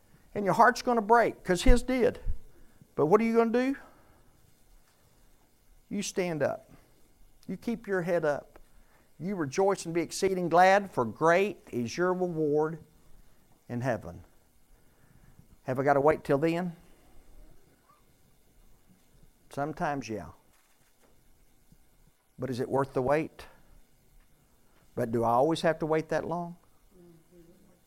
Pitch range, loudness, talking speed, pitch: 140-190 Hz, -28 LUFS, 130 wpm, 170 Hz